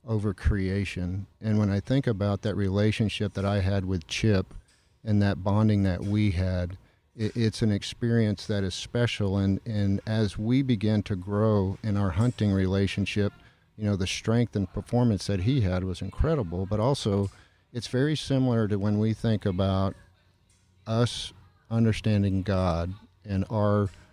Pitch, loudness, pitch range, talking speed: 100 Hz, -27 LUFS, 95-110 Hz, 160 wpm